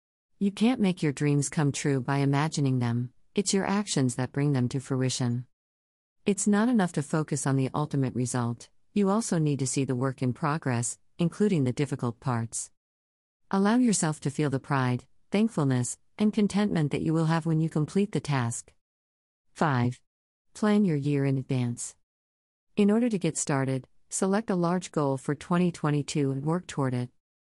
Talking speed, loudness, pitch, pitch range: 175 wpm, -28 LUFS, 140 Hz, 125-170 Hz